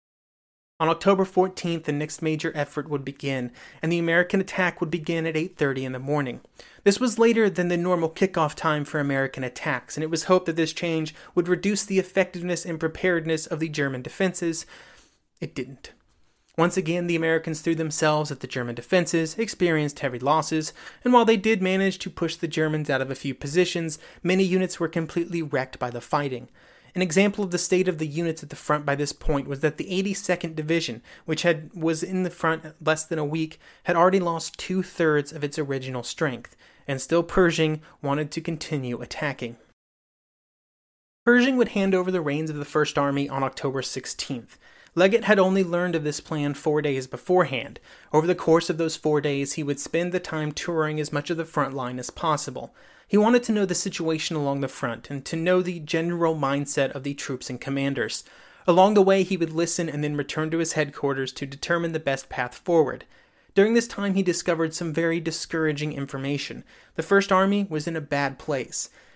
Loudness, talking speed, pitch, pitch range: -25 LUFS, 200 wpm, 160 Hz, 145-180 Hz